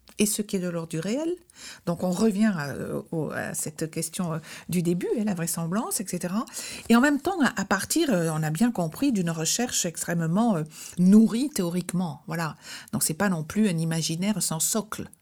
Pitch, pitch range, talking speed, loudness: 185 Hz, 165-220 Hz, 175 wpm, -26 LUFS